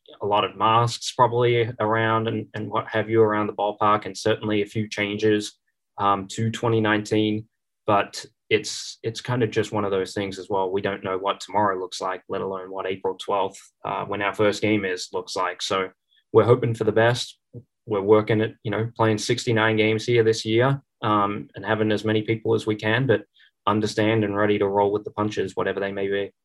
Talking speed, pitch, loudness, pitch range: 210 wpm, 110 Hz, -23 LUFS, 100-110 Hz